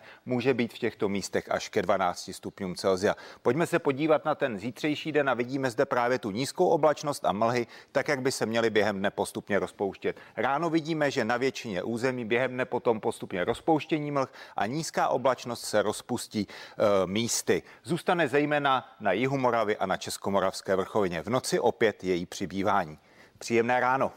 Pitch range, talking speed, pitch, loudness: 115-145 Hz, 175 wpm, 130 Hz, -28 LUFS